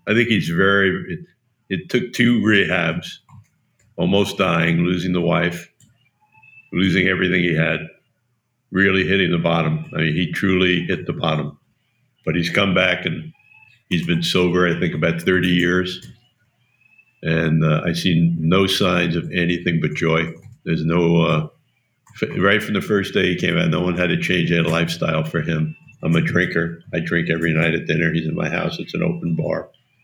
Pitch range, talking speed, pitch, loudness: 85-110 Hz, 180 wpm, 90 Hz, -19 LUFS